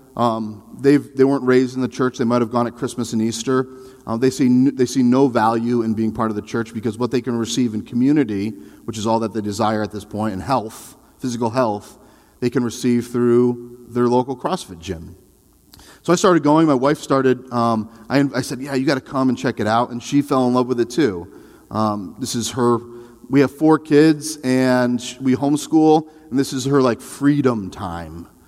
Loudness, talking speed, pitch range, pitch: -19 LUFS, 215 wpm, 115-130 Hz, 125 Hz